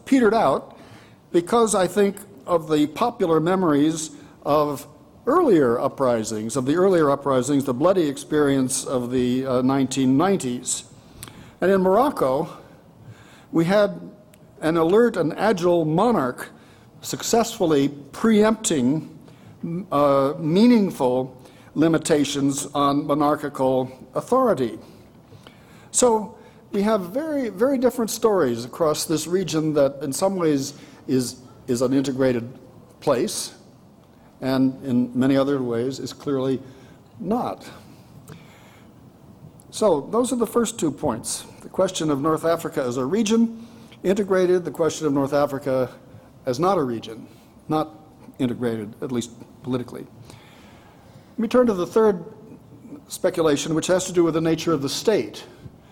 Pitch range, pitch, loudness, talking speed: 130-190 Hz, 150 Hz, -22 LUFS, 125 wpm